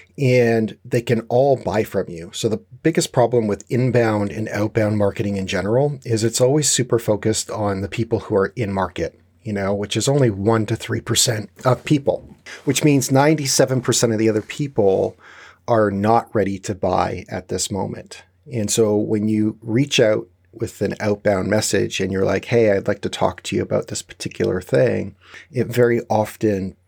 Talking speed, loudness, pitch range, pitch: 185 wpm, -20 LUFS, 105-125 Hz, 110 Hz